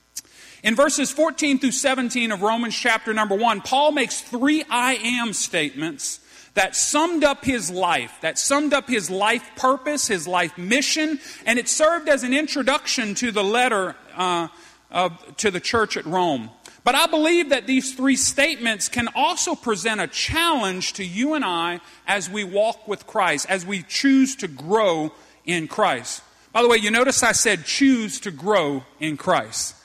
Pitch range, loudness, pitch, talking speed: 195-275 Hz, -21 LUFS, 235 Hz, 175 wpm